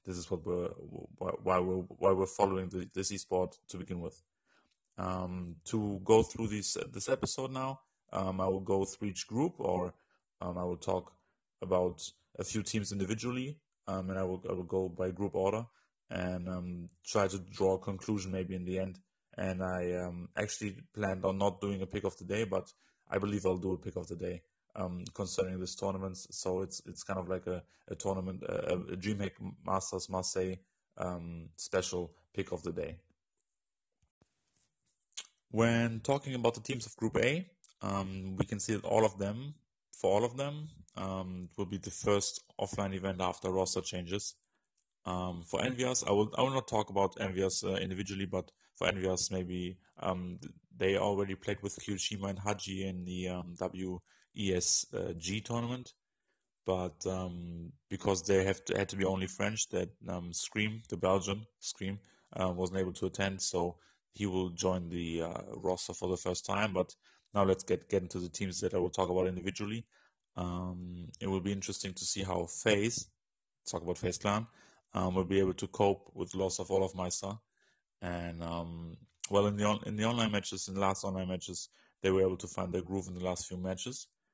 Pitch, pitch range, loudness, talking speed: 95 Hz, 90-100 Hz, -35 LUFS, 190 wpm